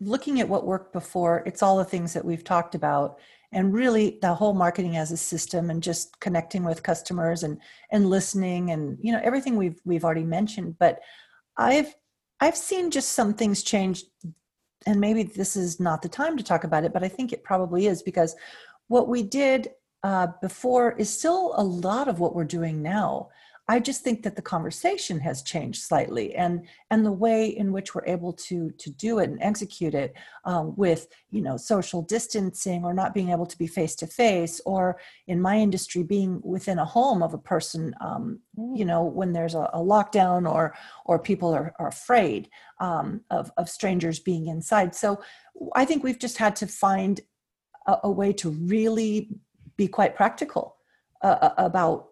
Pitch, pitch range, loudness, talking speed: 190 Hz, 170-215 Hz, -25 LUFS, 190 wpm